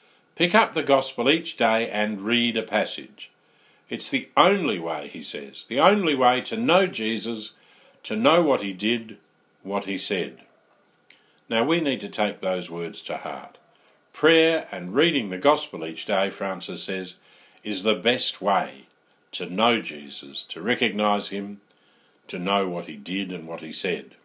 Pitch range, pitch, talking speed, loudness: 95-125 Hz, 105 Hz, 165 wpm, -24 LUFS